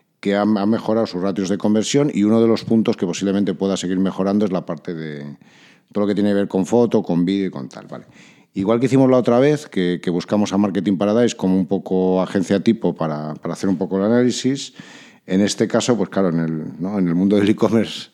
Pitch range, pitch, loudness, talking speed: 95-110 Hz, 100 Hz, -19 LUFS, 240 wpm